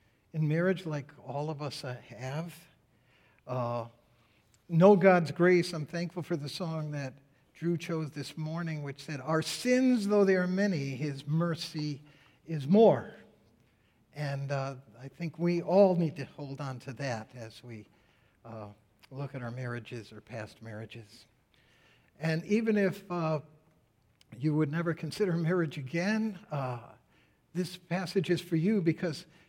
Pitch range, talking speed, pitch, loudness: 130-170 Hz, 145 wpm, 150 Hz, -31 LUFS